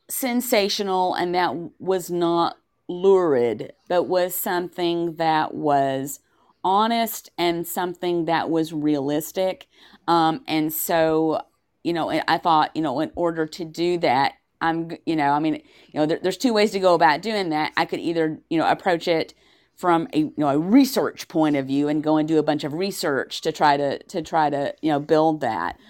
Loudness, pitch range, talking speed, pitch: -22 LUFS, 155-180 Hz, 190 wpm, 165 Hz